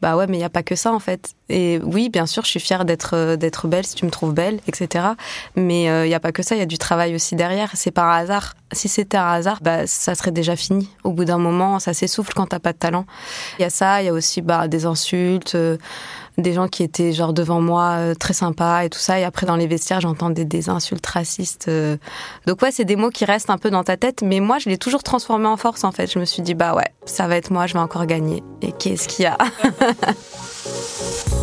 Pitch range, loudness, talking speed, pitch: 170-195 Hz, -19 LUFS, 260 wpm, 180 Hz